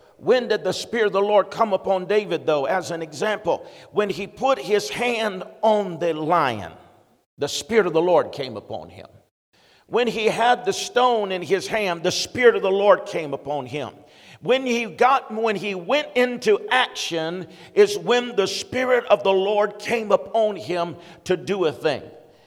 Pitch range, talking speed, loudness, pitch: 170-230 Hz, 180 wpm, -22 LUFS, 200 Hz